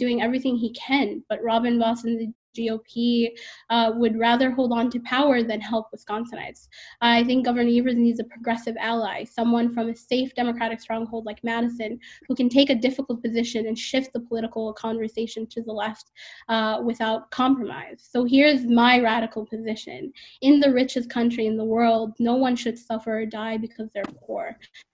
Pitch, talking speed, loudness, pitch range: 230 Hz, 180 wpm, -23 LUFS, 225-245 Hz